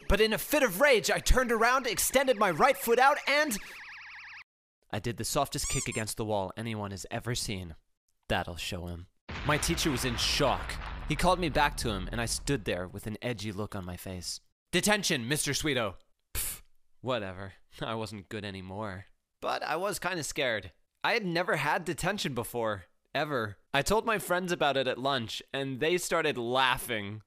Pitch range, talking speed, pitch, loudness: 105-175 Hz, 190 wpm, 125 Hz, -30 LUFS